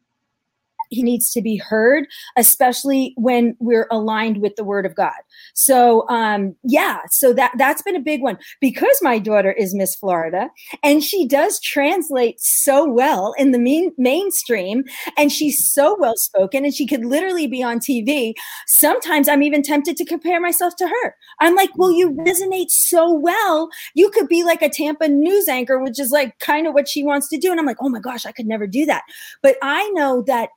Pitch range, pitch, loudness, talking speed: 240-335 Hz, 285 Hz, -16 LUFS, 200 wpm